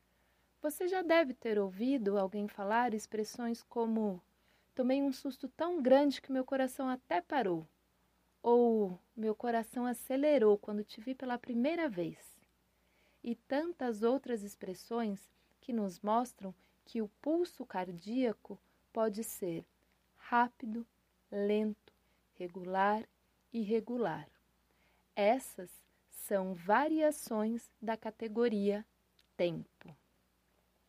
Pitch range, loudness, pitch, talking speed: 200-255 Hz, -35 LUFS, 225 Hz, 105 wpm